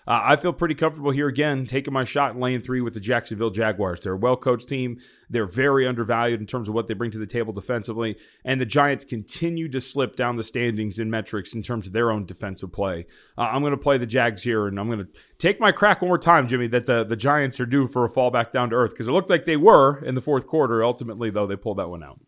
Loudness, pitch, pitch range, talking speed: -23 LUFS, 125 Hz, 115-140 Hz, 275 wpm